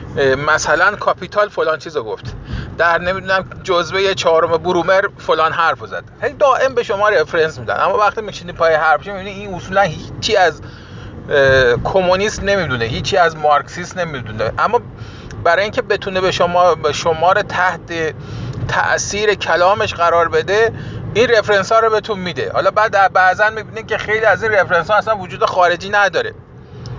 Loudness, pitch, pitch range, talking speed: -15 LUFS, 180 Hz, 155-200 Hz, 150 wpm